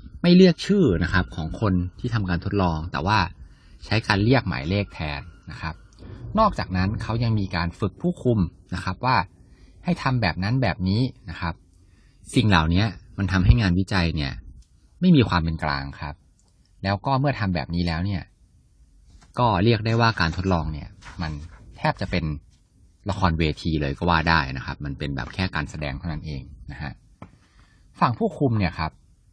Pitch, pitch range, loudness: 90 Hz, 80-110 Hz, -23 LUFS